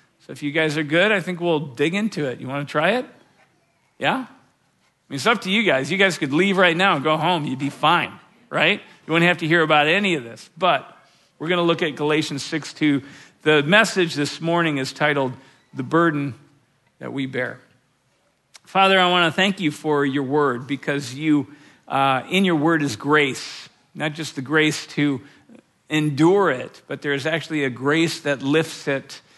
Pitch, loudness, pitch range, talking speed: 150 Hz, -20 LUFS, 140-170 Hz, 200 wpm